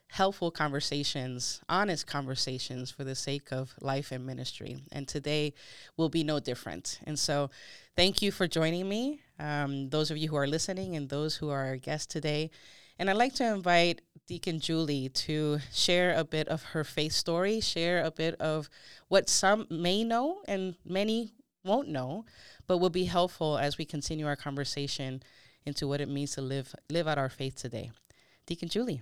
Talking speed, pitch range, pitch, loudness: 180 wpm, 140-175 Hz, 155 Hz, -31 LUFS